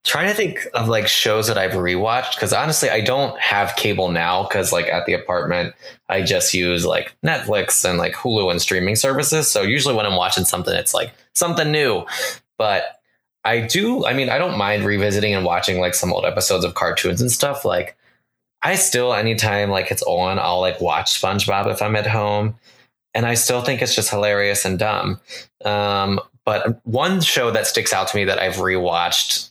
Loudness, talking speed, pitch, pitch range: -18 LUFS, 195 wpm, 105 Hz, 95-125 Hz